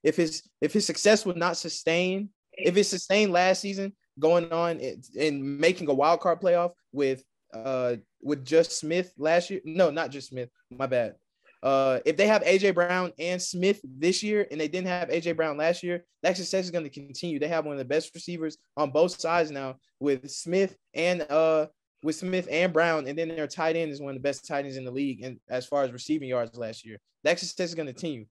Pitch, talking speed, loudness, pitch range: 165 Hz, 225 wpm, -27 LUFS, 140-180 Hz